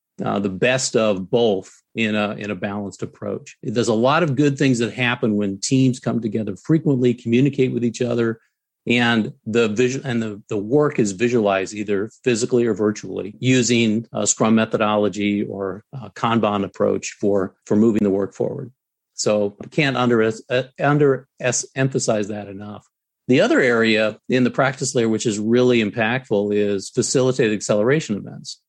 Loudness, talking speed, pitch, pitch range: -20 LUFS, 165 wpm, 115 Hz, 105-125 Hz